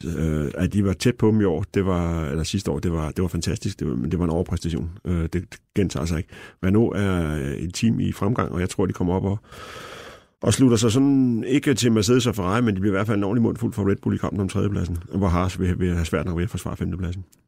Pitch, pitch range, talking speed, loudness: 95 Hz, 85-110 Hz, 280 wpm, -23 LUFS